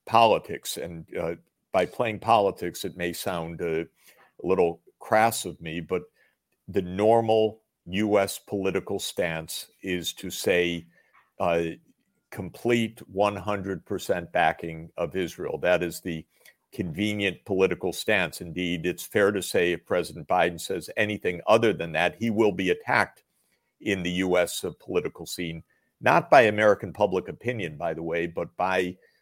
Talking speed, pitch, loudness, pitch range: 140 wpm, 90 Hz, -26 LUFS, 85-105 Hz